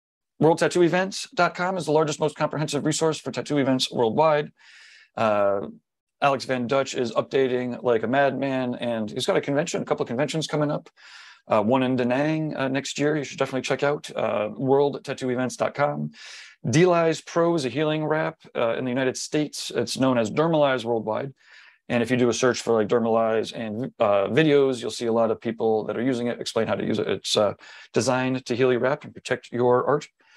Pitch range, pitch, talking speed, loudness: 120-150 Hz, 130 Hz, 200 wpm, -24 LUFS